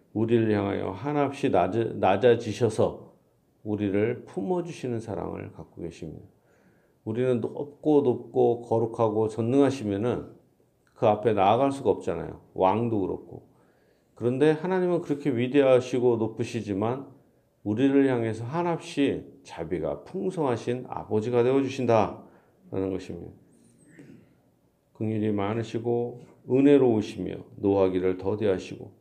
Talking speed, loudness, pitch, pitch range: 285 characters per minute, -26 LUFS, 120 Hz, 105-135 Hz